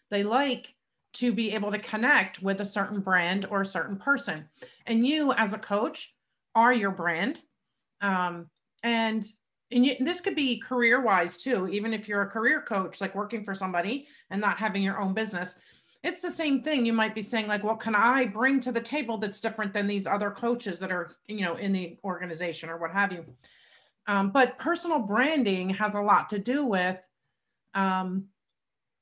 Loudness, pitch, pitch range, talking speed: -27 LUFS, 210 Hz, 195-245 Hz, 195 wpm